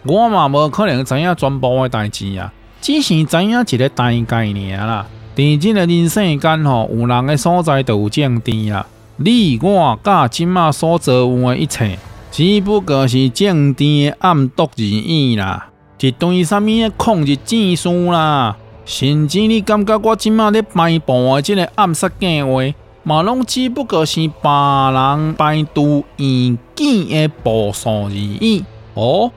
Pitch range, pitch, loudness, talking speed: 120-180 Hz, 145 Hz, -14 LUFS, 220 characters per minute